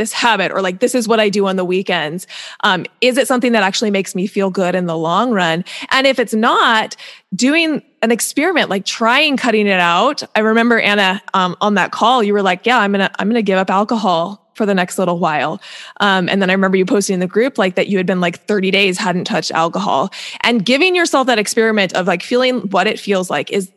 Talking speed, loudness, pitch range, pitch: 240 wpm, -14 LUFS, 185-235 Hz, 205 Hz